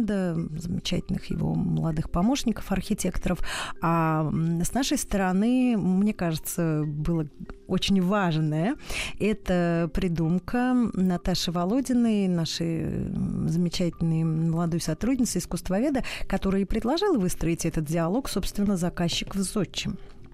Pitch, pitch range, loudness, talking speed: 185 Hz, 165-205 Hz, -26 LUFS, 95 wpm